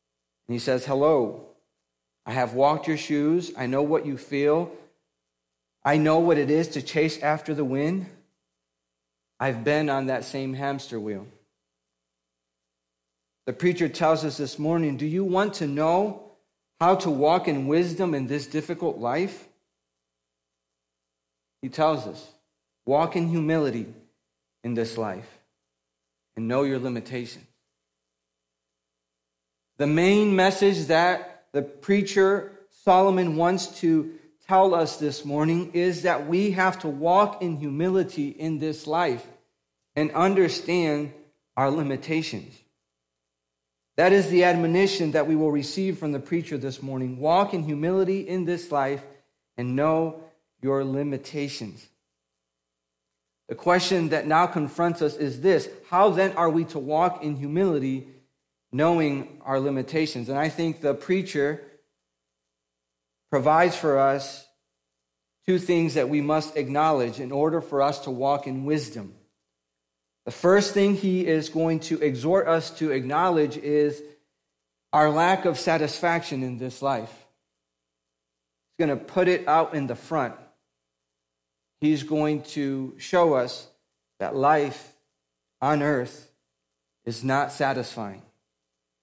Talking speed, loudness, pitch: 130 wpm, -24 LUFS, 145 Hz